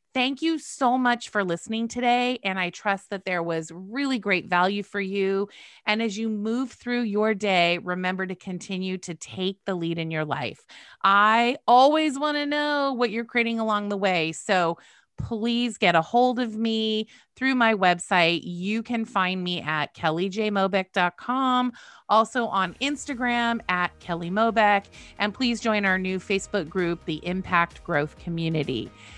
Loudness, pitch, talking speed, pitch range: -24 LUFS, 205 Hz, 160 wpm, 180-235 Hz